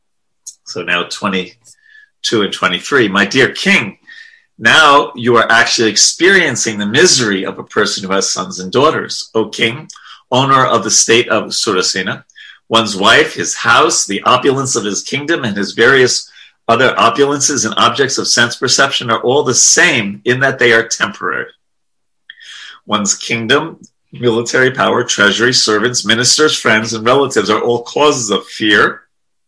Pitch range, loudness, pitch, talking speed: 105-145 Hz, -11 LUFS, 120 Hz, 150 wpm